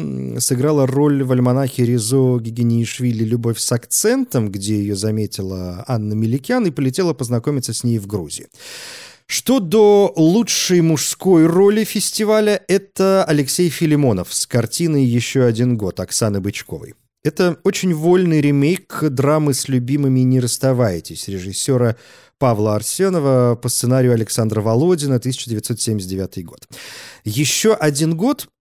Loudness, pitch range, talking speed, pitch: -17 LUFS, 115-165 Hz, 120 wpm, 130 Hz